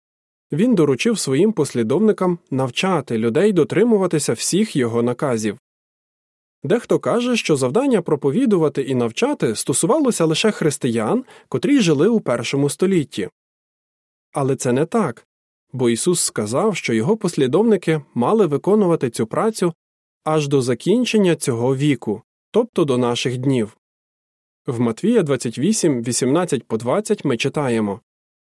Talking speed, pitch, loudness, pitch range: 120 wpm, 150 Hz, -19 LUFS, 125-205 Hz